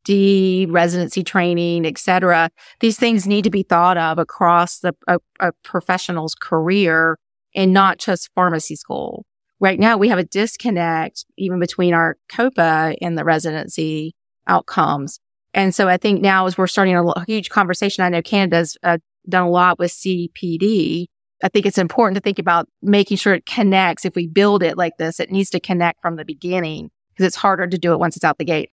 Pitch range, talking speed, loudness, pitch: 170-195 Hz, 195 wpm, -17 LUFS, 180 Hz